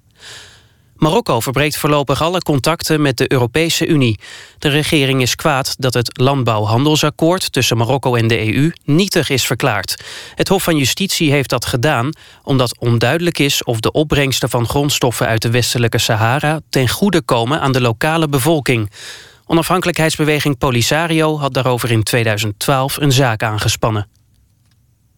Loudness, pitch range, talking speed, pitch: -15 LUFS, 120-155 Hz, 140 wpm, 135 Hz